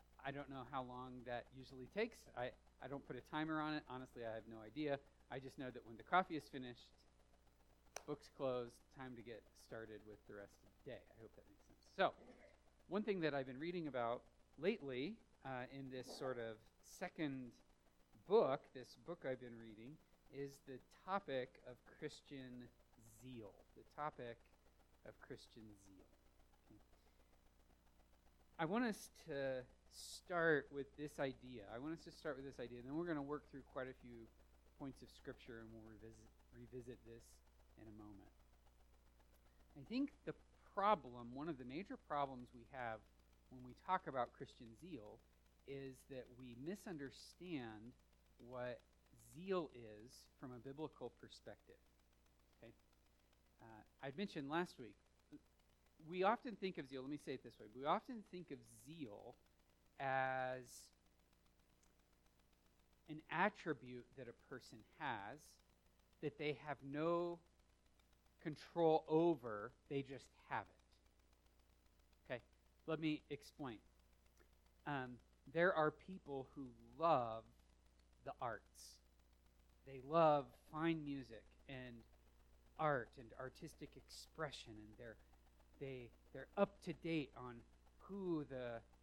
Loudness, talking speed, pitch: -46 LUFS, 145 wpm, 125 Hz